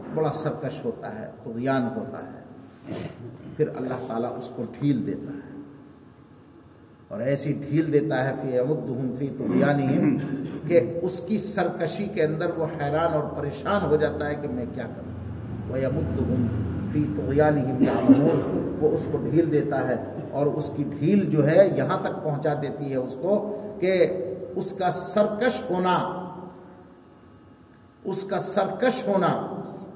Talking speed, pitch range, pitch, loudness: 145 wpm, 135-180 Hz, 150 Hz, -25 LUFS